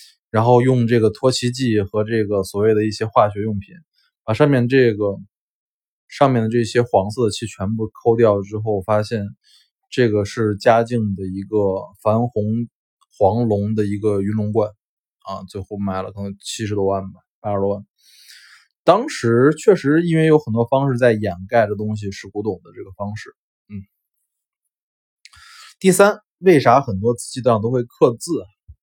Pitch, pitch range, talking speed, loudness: 110 Hz, 100-120 Hz, 240 characters per minute, -18 LUFS